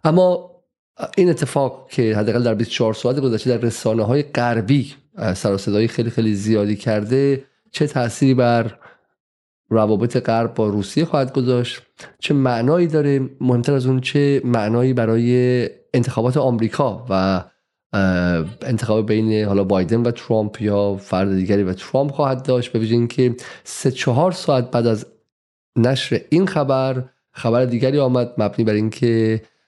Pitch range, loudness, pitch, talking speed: 110-135 Hz, -19 LUFS, 120 Hz, 140 wpm